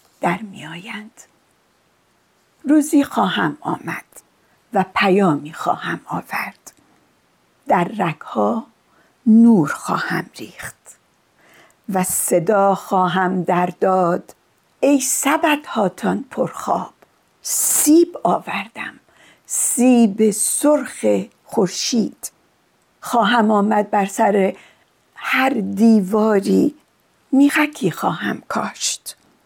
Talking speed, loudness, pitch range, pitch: 75 wpm, -18 LUFS, 190-260 Hz, 215 Hz